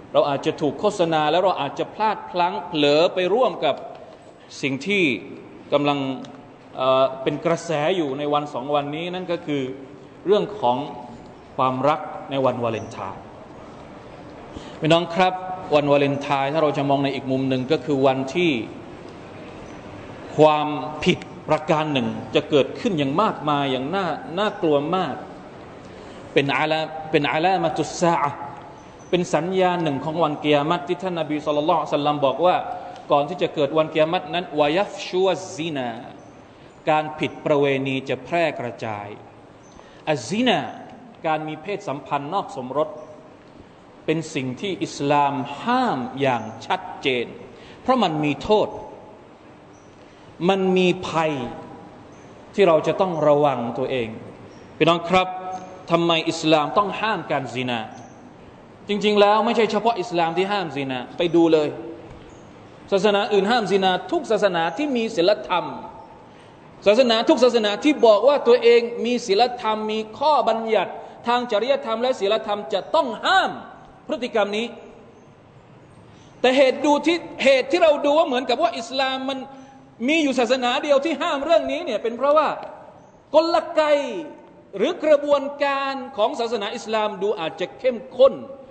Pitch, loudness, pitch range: 175 Hz, -21 LUFS, 145-230 Hz